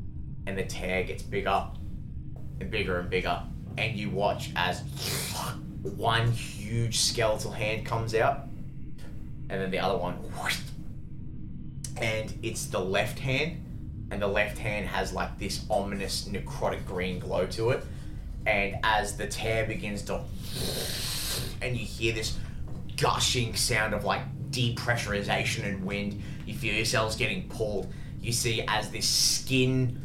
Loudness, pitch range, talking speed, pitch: -29 LUFS, 100-125 Hz, 140 wpm, 110 Hz